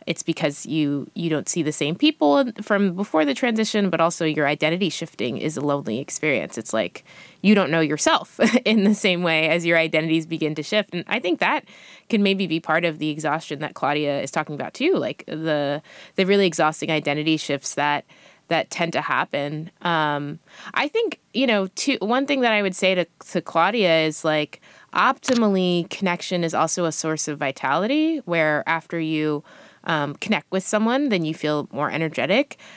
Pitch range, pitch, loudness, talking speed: 155-195 Hz, 165 Hz, -22 LUFS, 190 wpm